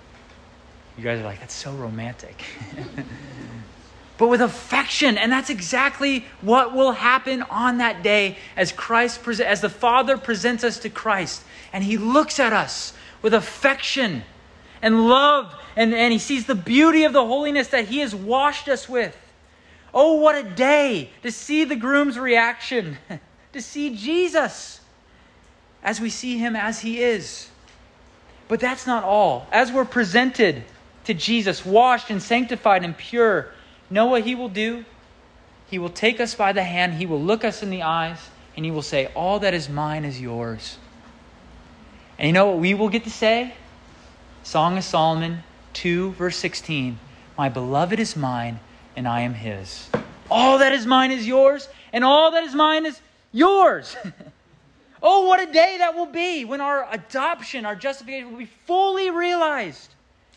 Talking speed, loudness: 165 wpm, -20 LUFS